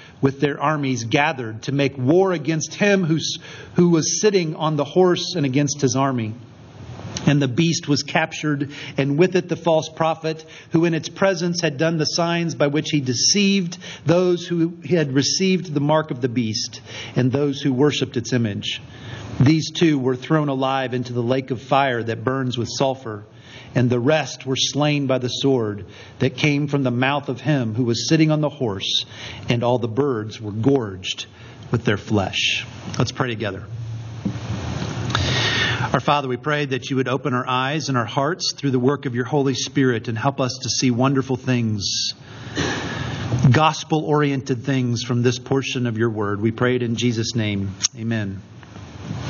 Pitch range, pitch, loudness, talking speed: 120-150 Hz, 135 Hz, -21 LUFS, 180 wpm